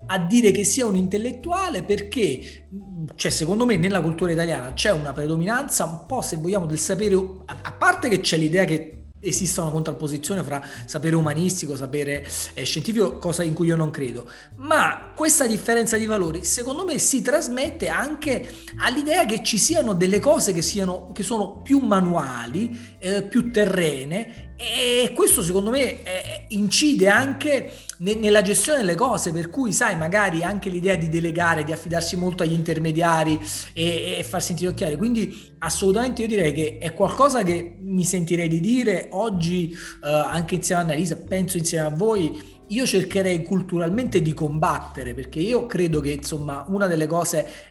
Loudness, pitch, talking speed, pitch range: -22 LUFS, 185 Hz, 165 wpm, 165-220 Hz